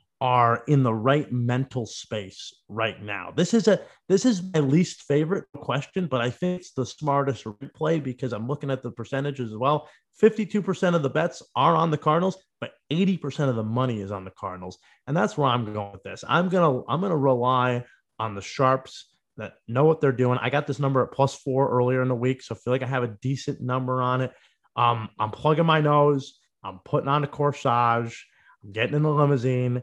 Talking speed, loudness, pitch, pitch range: 215 wpm, -24 LUFS, 135 Hz, 125-155 Hz